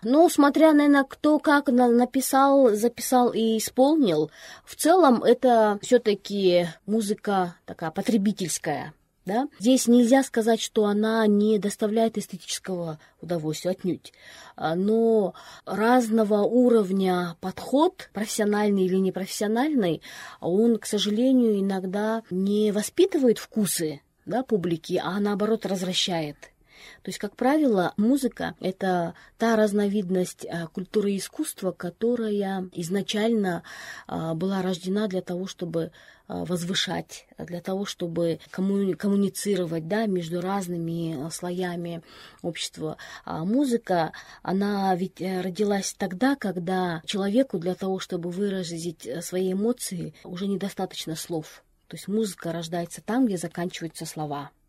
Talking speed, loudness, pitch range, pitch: 110 wpm, -25 LUFS, 180-225 Hz, 200 Hz